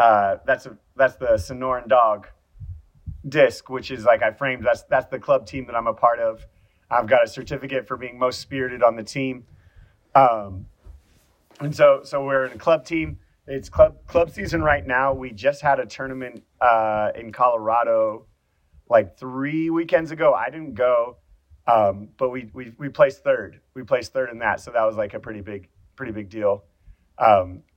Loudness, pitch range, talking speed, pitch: -21 LUFS, 100-140 Hz, 200 wpm, 125 Hz